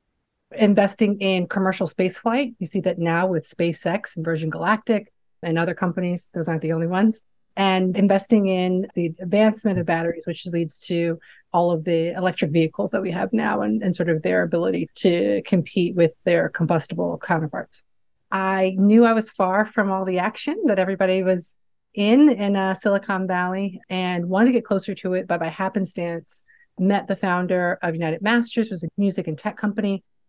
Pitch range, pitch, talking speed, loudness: 170-200 Hz, 185 Hz, 180 wpm, -22 LUFS